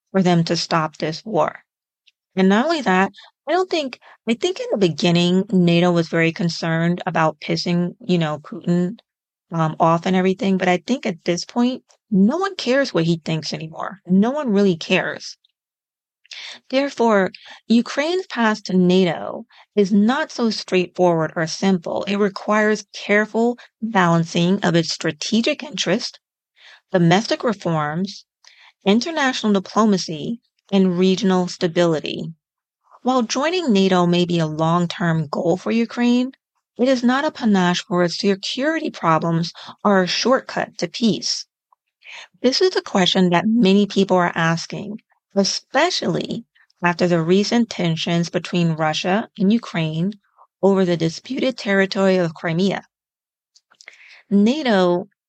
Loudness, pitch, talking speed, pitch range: -19 LUFS, 190 Hz, 135 wpm, 175-225 Hz